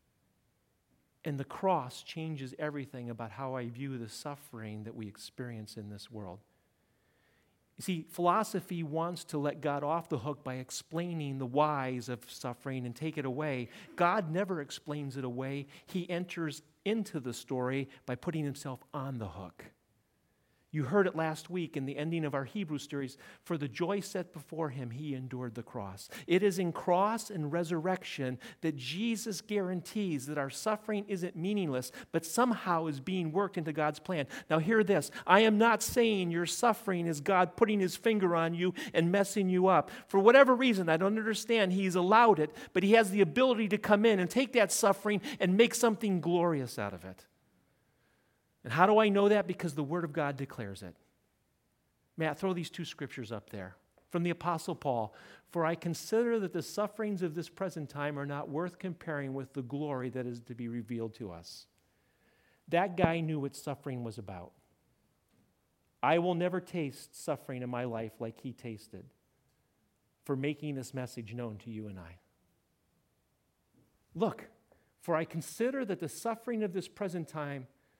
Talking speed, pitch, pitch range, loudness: 180 wpm, 160 Hz, 130-185 Hz, -32 LUFS